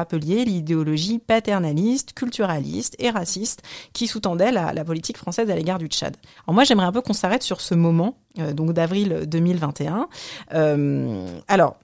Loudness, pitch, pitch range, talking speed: -22 LUFS, 180 Hz, 160-225 Hz, 155 wpm